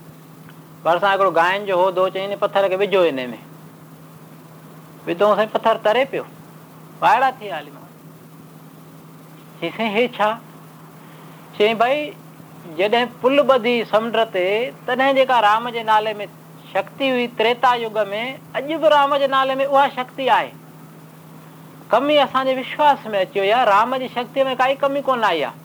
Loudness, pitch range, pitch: -18 LUFS, 195-260 Hz, 225 Hz